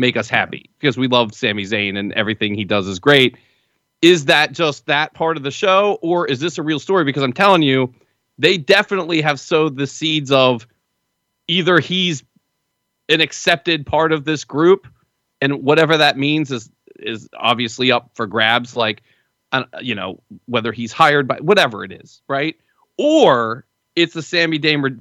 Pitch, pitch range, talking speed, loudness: 145 Hz, 125-165 Hz, 175 wpm, -16 LUFS